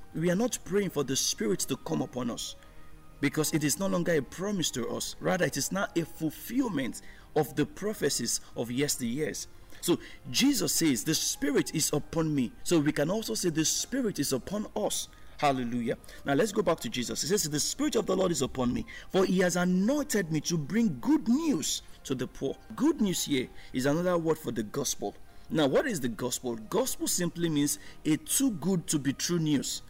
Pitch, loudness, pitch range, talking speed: 160 Hz, -29 LUFS, 140-205 Hz, 205 wpm